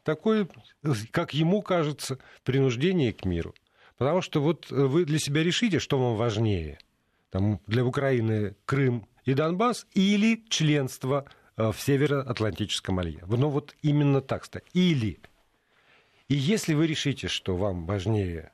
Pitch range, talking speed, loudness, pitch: 110-155 Hz, 130 wpm, -27 LUFS, 135 Hz